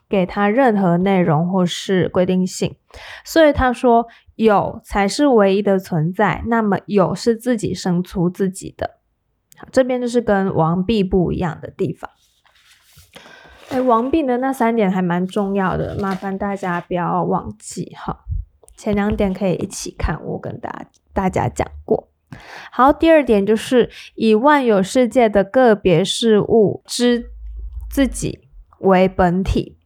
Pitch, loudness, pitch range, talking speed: 200 Hz, -17 LUFS, 185-235 Hz, 215 characters per minute